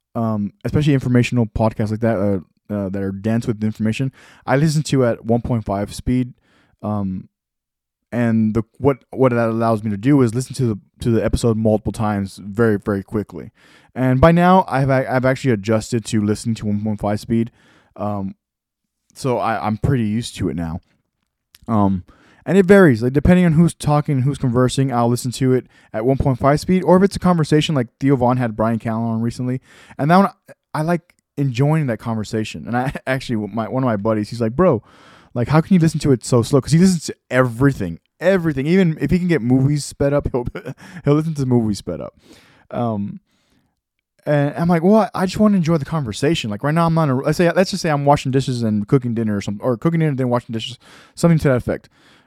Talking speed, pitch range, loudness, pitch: 220 wpm, 110-145 Hz, -18 LUFS, 125 Hz